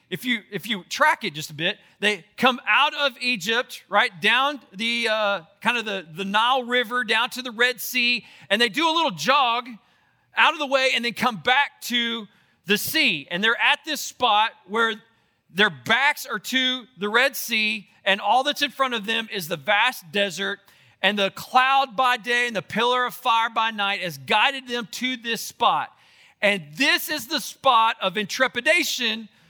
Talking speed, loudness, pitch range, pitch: 195 wpm, -22 LUFS, 200-255 Hz, 230 Hz